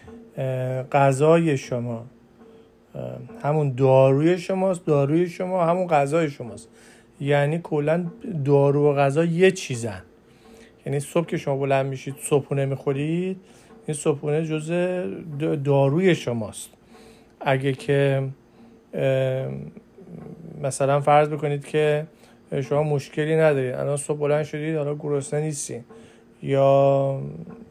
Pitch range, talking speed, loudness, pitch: 135-160 Hz, 100 wpm, -22 LUFS, 145 Hz